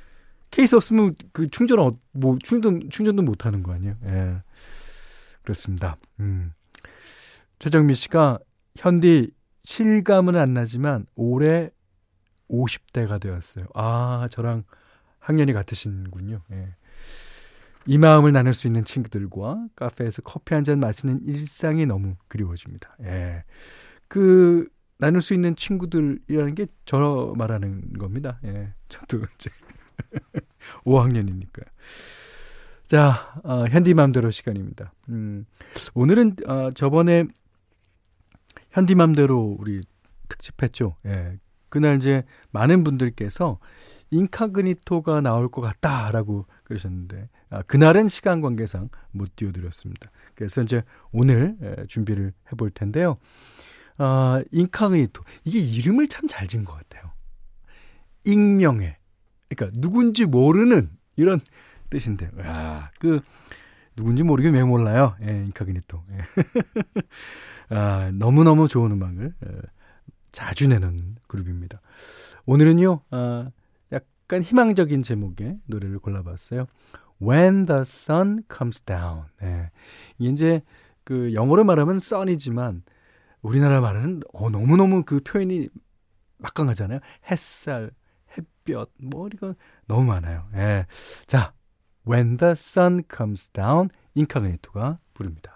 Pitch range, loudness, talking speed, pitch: 100-155 Hz, -21 LUFS, 265 characters per minute, 120 Hz